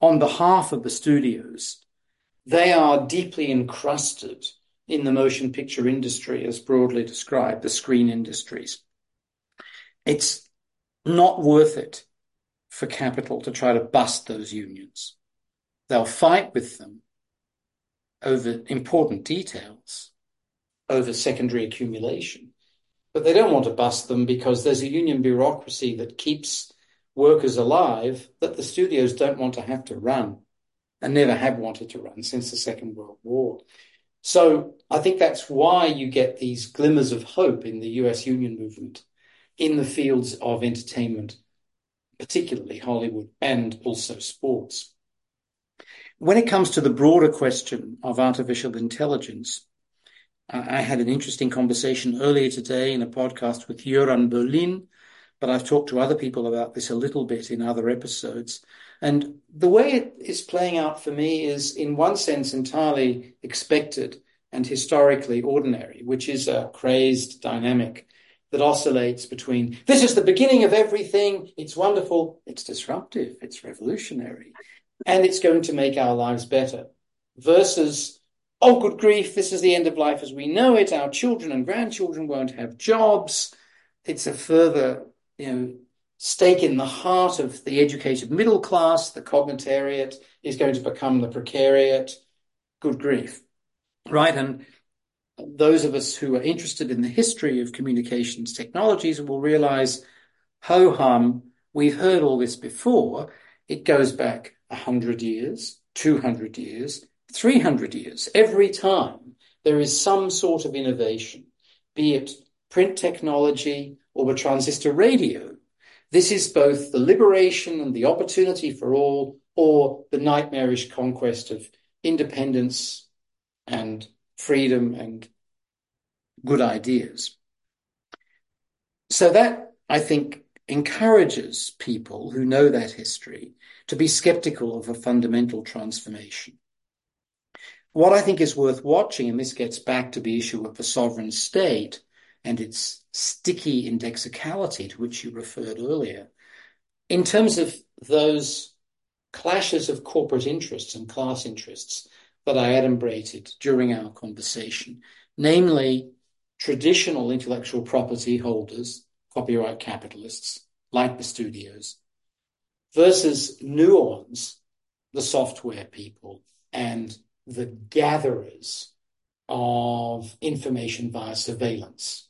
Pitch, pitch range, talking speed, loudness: 130 Hz, 120-155 Hz, 135 wpm, -22 LUFS